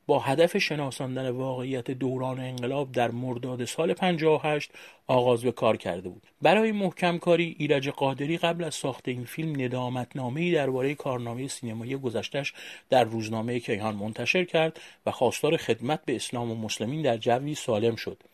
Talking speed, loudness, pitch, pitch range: 155 wpm, -28 LUFS, 130 Hz, 125-150 Hz